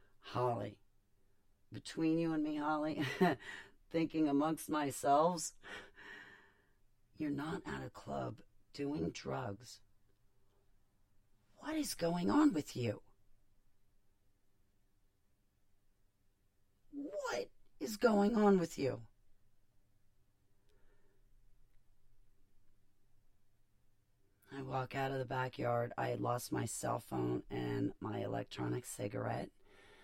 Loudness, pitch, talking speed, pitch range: -38 LUFS, 100 Hz, 90 wpm, 100-135 Hz